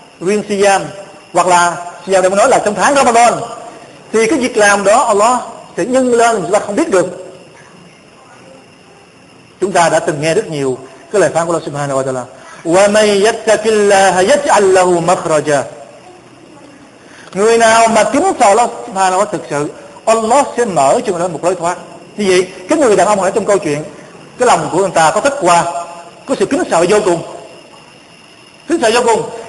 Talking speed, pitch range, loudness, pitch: 185 wpm, 170-225 Hz, -12 LUFS, 190 Hz